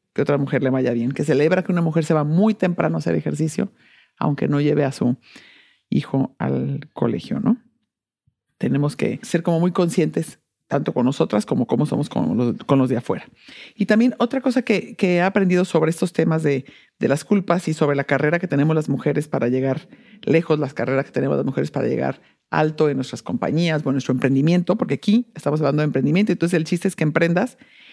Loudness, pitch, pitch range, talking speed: -21 LUFS, 155 Hz, 135-185 Hz, 215 wpm